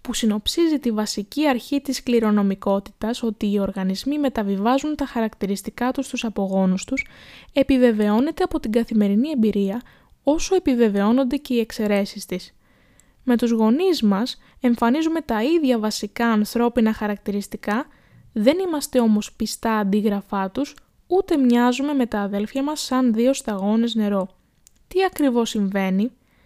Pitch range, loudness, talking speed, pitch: 210-270 Hz, -21 LUFS, 130 wpm, 235 Hz